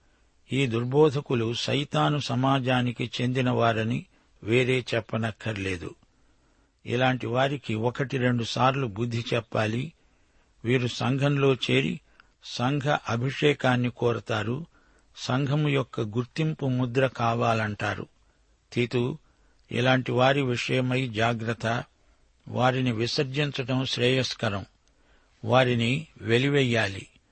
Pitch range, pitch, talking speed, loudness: 115-130 Hz, 125 Hz, 75 wpm, -26 LUFS